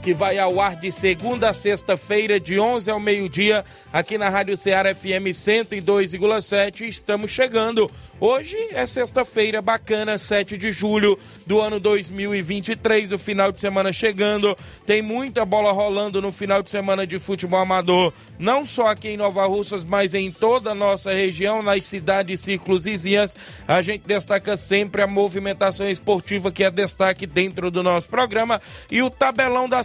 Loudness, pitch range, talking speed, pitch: -20 LUFS, 195-215 Hz, 165 wpm, 200 Hz